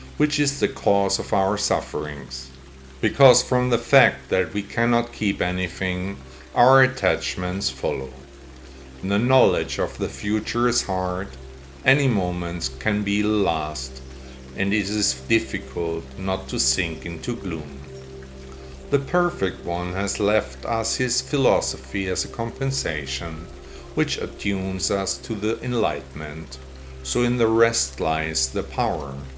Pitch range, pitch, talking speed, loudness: 65-110 Hz, 90 Hz, 130 wpm, -23 LUFS